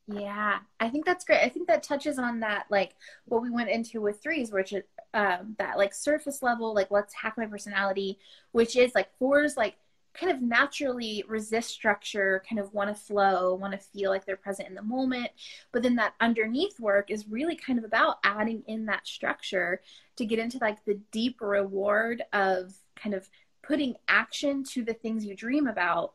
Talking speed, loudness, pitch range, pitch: 195 wpm, -28 LUFS, 200-255 Hz, 220 Hz